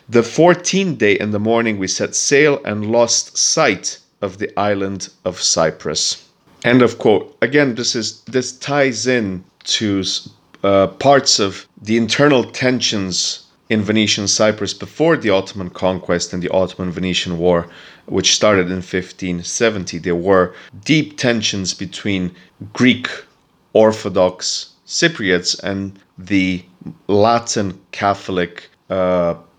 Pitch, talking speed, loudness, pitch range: 100 Hz, 125 wpm, -16 LUFS, 90-115 Hz